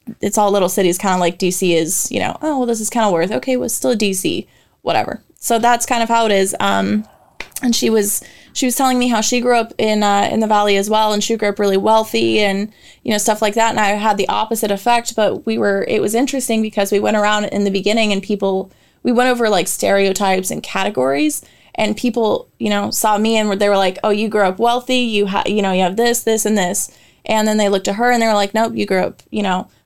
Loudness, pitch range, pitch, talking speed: -16 LUFS, 195-230 Hz, 210 Hz, 265 wpm